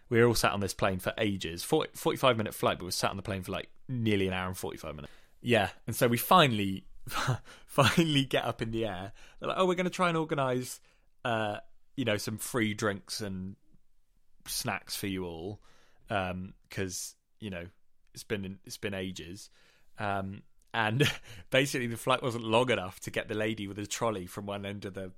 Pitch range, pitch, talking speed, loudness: 100-125 Hz, 110 Hz, 210 wpm, -31 LUFS